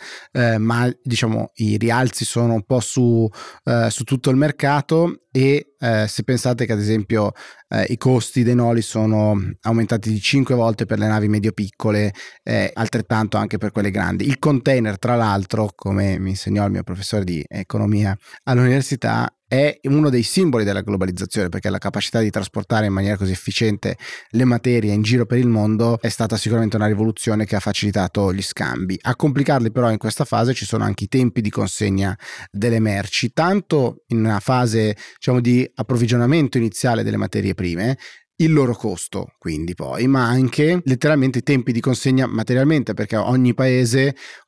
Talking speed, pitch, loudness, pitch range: 175 wpm, 115 Hz, -19 LUFS, 105-125 Hz